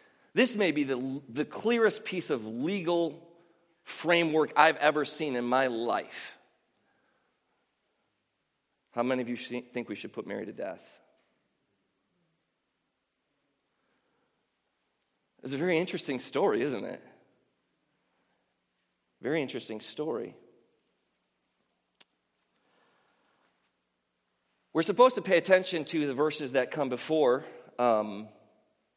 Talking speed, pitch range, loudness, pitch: 100 wpm, 125-170 Hz, -29 LUFS, 150 Hz